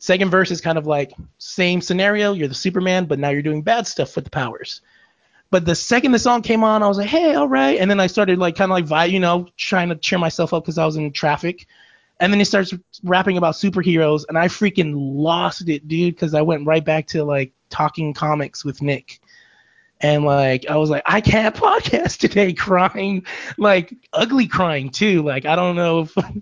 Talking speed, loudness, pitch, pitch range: 220 wpm, -18 LUFS, 175 Hz, 150-190 Hz